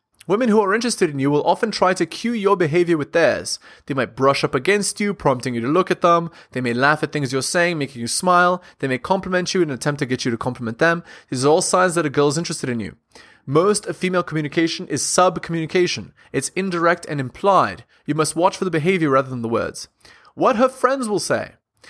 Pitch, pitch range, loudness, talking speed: 170 Hz, 140-185 Hz, -19 LUFS, 235 wpm